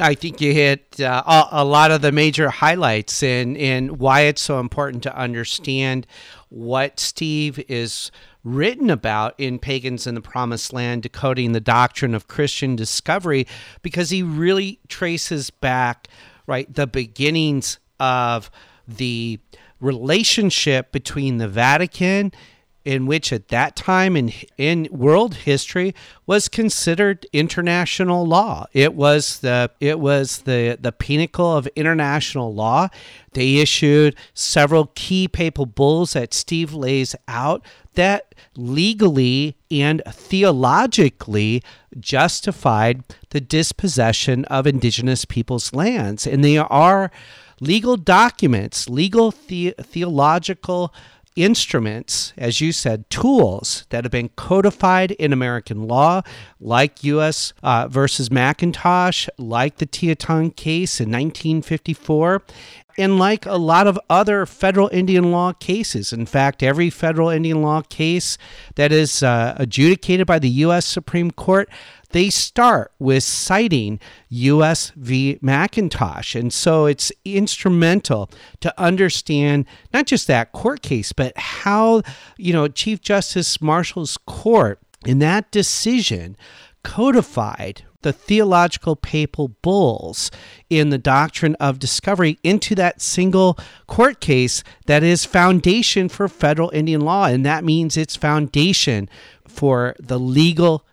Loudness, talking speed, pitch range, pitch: -18 LUFS, 125 wpm, 125-175 Hz, 150 Hz